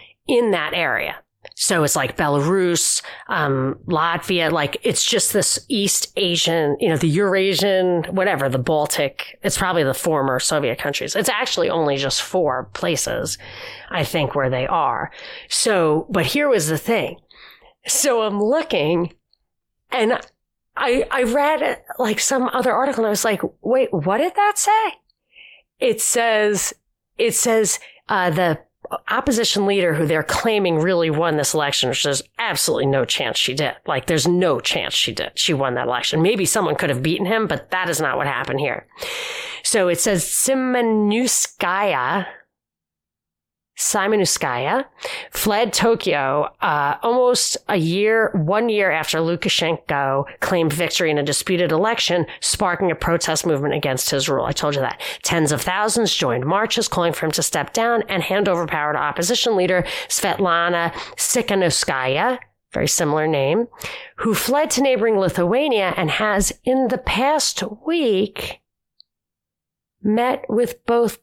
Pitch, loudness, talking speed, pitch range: 185 Hz, -19 LUFS, 150 wpm, 160-230 Hz